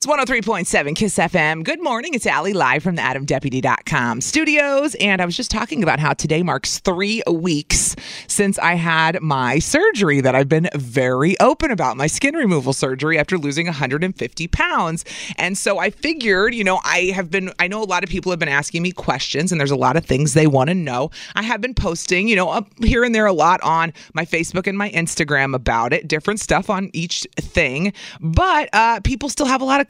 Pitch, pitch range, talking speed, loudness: 175 Hz, 150-210 Hz, 215 wpm, -18 LUFS